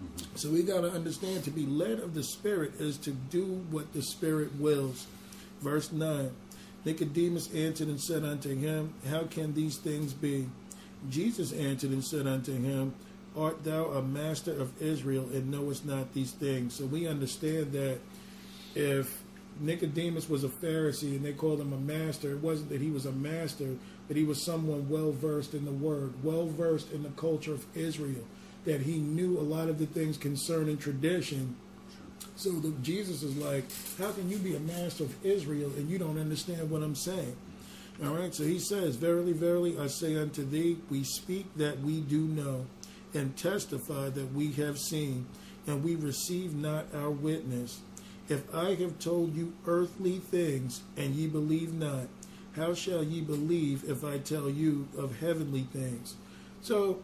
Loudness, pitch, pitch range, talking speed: -34 LUFS, 155 Hz, 145-170 Hz, 175 wpm